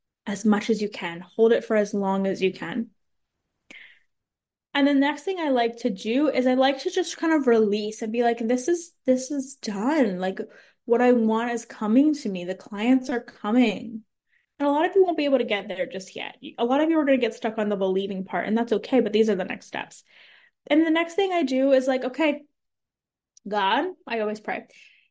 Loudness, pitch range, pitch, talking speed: -24 LUFS, 210-280 Hz, 235 Hz, 230 wpm